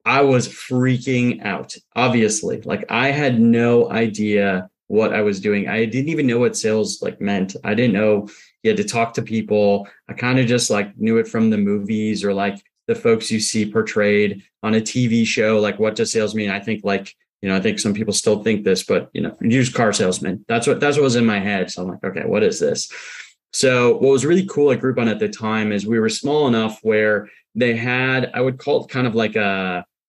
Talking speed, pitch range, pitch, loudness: 230 wpm, 105-125 Hz, 110 Hz, -19 LUFS